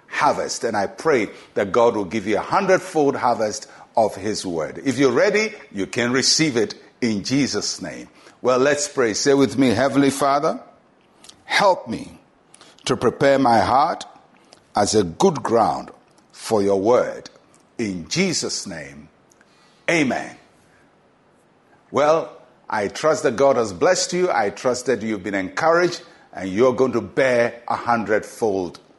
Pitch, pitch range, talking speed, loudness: 130 Hz, 110-145 Hz, 145 wpm, -20 LUFS